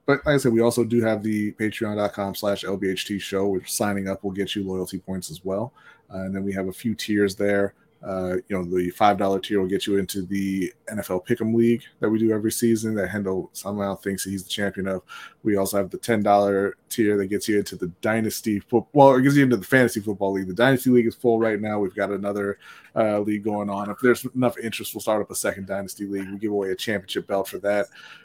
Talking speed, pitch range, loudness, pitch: 245 wpm, 95-110 Hz, -23 LUFS, 100 Hz